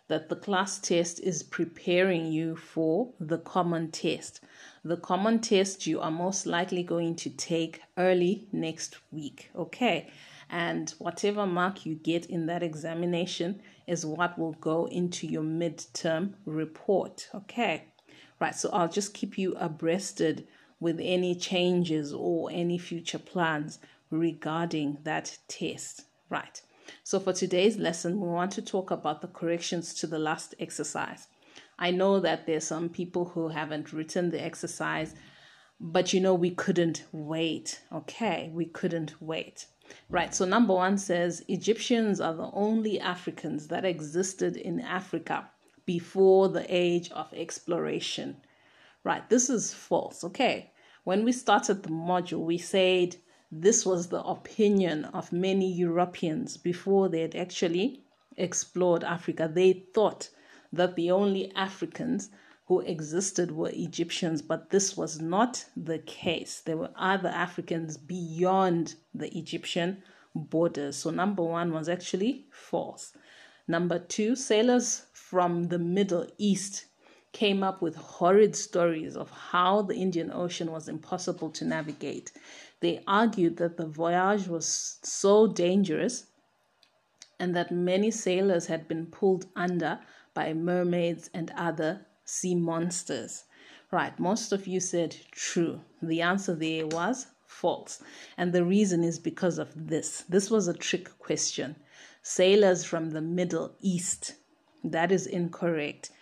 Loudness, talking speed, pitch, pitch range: -29 LUFS, 140 wpm, 175 Hz, 165-190 Hz